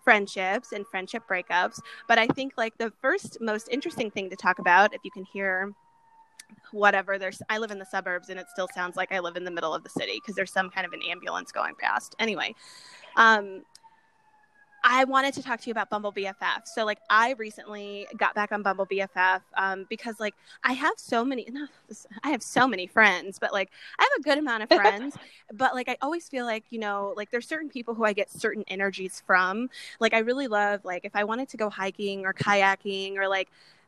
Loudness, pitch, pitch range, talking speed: -26 LUFS, 210 Hz, 195-245 Hz, 220 wpm